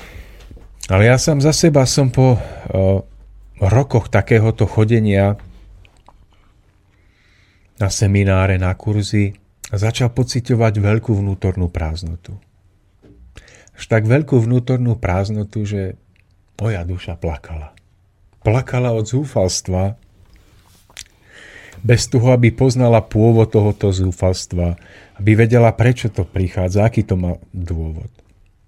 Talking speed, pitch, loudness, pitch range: 100 wpm, 100 Hz, -16 LUFS, 95-115 Hz